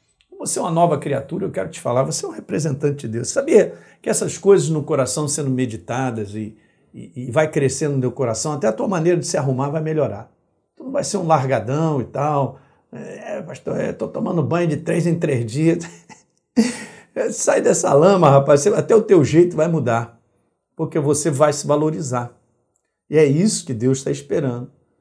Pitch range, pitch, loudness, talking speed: 130-170 Hz, 150 Hz, -19 LUFS, 195 wpm